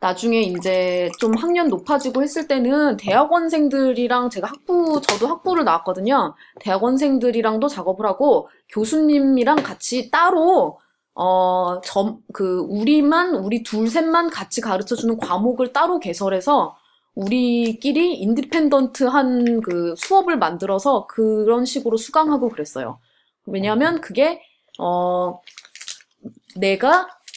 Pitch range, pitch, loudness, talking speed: 195-295 Hz, 245 Hz, -19 LUFS, 275 characters per minute